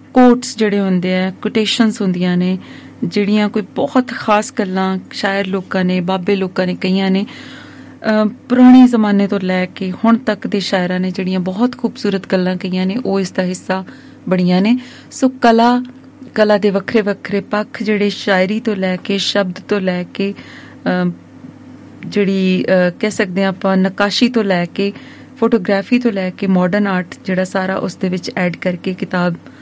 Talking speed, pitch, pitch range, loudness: 165 wpm, 200 Hz, 185-225 Hz, -15 LUFS